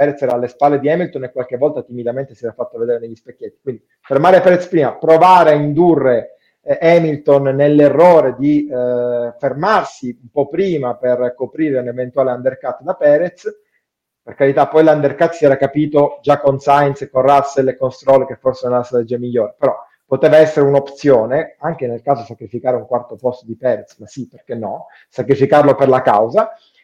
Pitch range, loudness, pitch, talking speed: 125-155 Hz, -14 LUFS, 140 Hz, 185 wpm